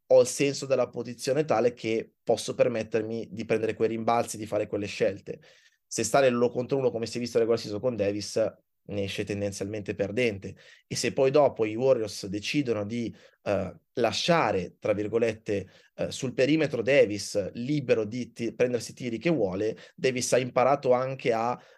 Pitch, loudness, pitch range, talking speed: 115 Hz, -27 LUFS, 105-130 Hz, 170 wpm